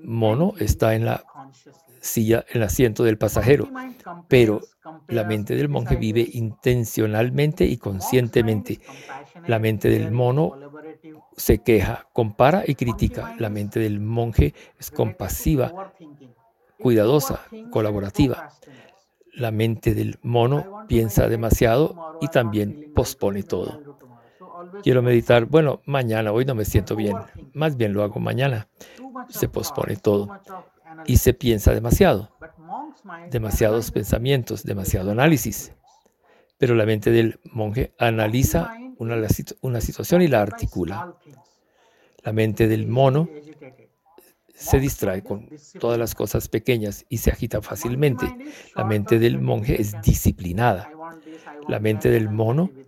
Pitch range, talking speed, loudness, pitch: 110-150 Hz, 125 wpm, -22 LUFS, 120 Hz